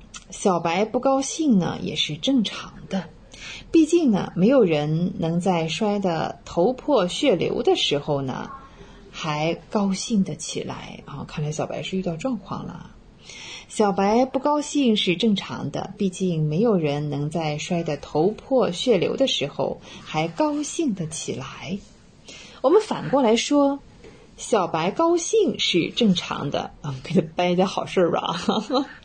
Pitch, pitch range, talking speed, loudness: 200 Hz, 165-255 Hz, 210 characters per minute, -23 LUFS